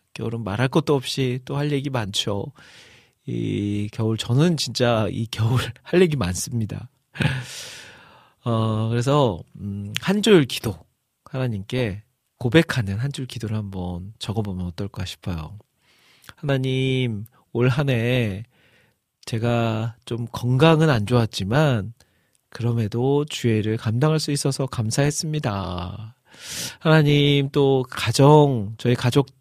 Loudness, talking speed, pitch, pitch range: -22 LUFS, 230 characters per minute, 120 Hz, 110-135 Hz